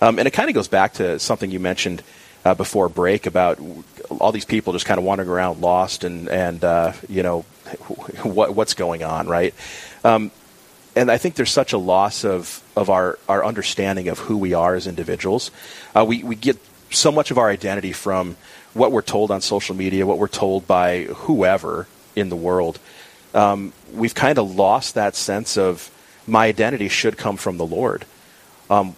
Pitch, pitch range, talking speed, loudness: 95 Hz, 90-105 Hz, 195 wpm, -19 LUFS